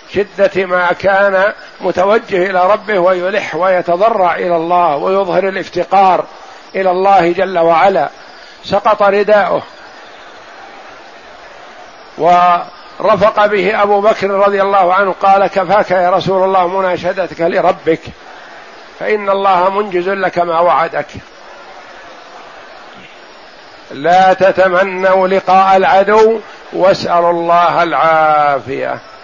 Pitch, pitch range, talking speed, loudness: 190 Hz, 175-195 Hz, 90 wpm, -11 LUFS